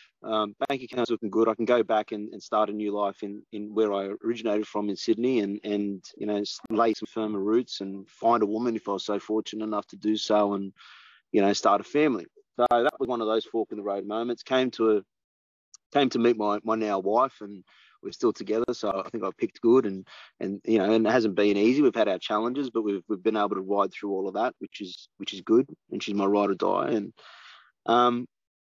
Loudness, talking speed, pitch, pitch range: -26 LUFS, 245 wpm, 105 Hz, 100-115 Hz